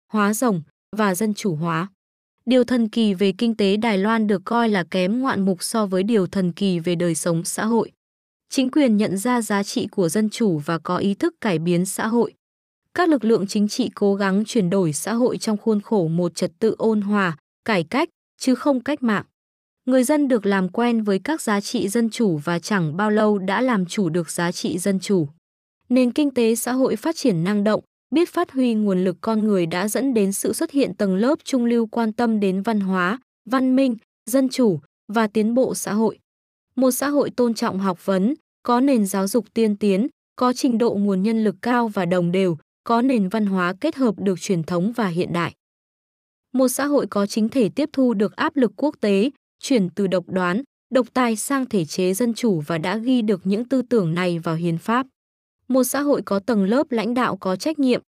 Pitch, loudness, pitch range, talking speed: 220 Hz, -21 LUFS, 195-245 Hz, 225 wpm